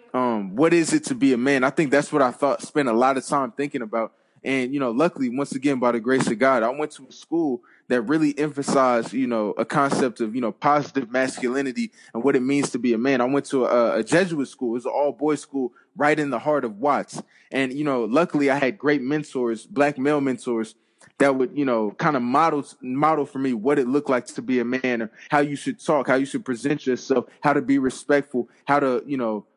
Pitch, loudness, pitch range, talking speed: 140 Hz, -22 LUFS, 125-145 Hz, 250 wpm